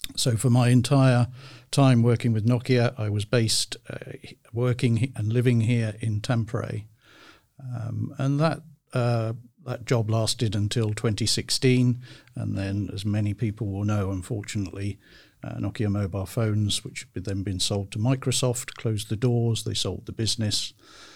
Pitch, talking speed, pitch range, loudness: 115 Hz, 150 wpm, 105-125 Hz, -25 LUFS